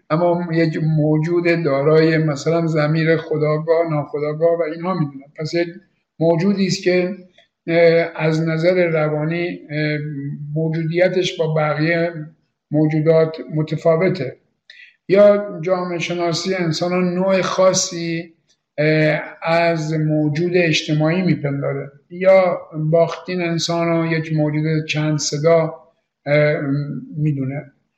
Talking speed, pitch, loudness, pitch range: 90 wpm, 165 Hz, -18 LUFS, 155-175 Hz